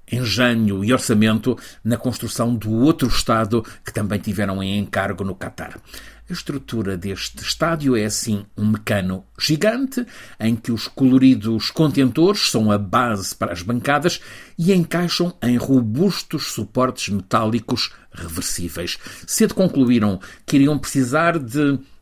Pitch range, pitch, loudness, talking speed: 105-140 Hz, 120 Hz, -20 LUFS, 130 wpm